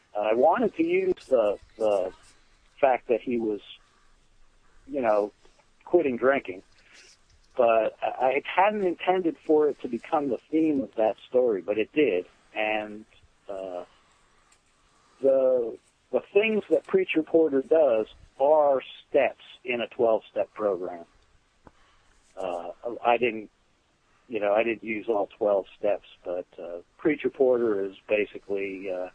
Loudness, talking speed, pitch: -26 LUFS, 130 wpm, 125 Hz